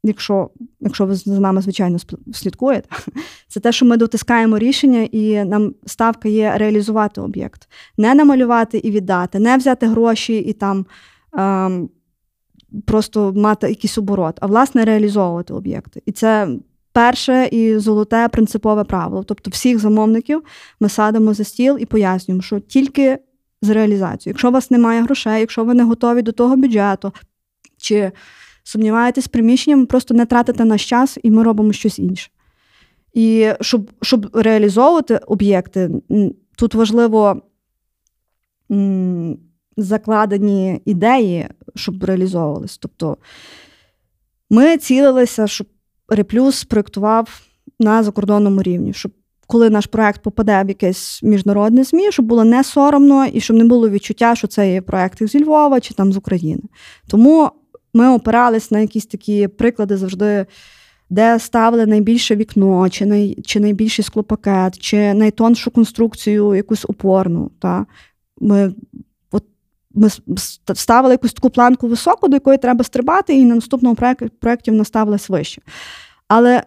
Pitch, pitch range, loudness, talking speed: 220 Hz, 205-240 Hz, -15 LUFS, 135 wpm